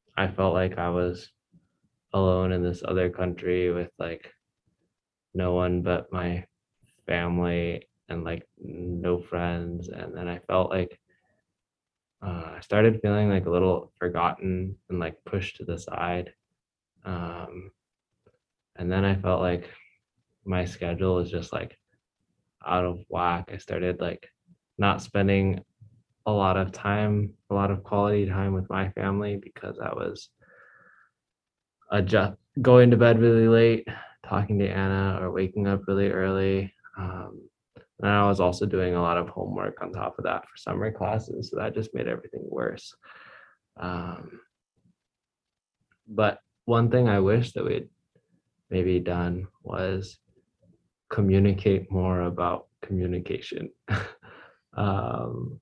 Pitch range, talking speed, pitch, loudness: 90-100 Hz, 135 wpm, 95 Hz, -26 LUFS